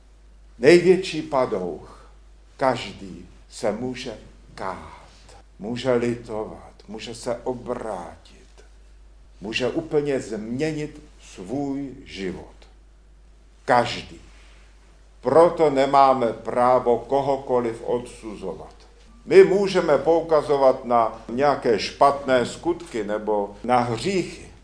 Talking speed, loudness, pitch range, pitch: 80 wpm, -22 LUFS, 100-140 Hz, 120 Hz